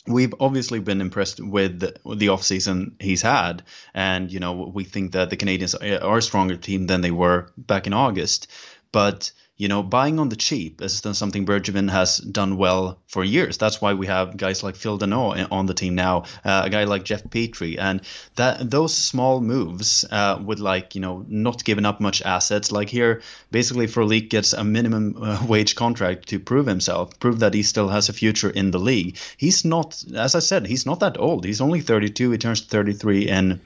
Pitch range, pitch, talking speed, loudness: 95-115 Hz, 100 Hz, 200 wpm, -21 LUFS